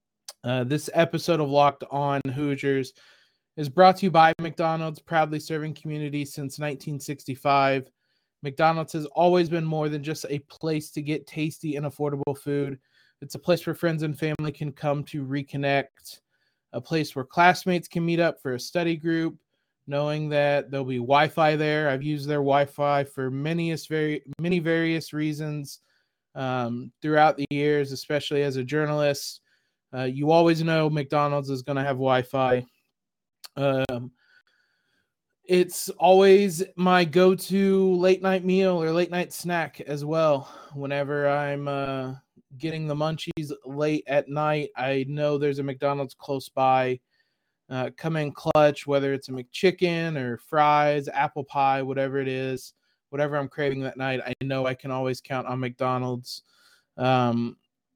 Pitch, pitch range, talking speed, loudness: 145 Hz, 135-160 Hz, 155 wpm, -25 LUFS